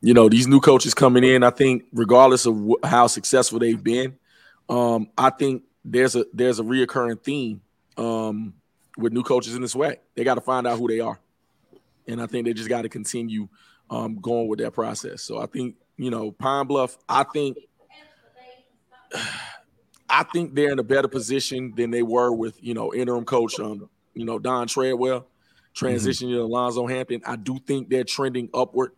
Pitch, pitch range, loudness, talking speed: 125 Hz, 115-130 Hz, -22 LUFS, 185 wpm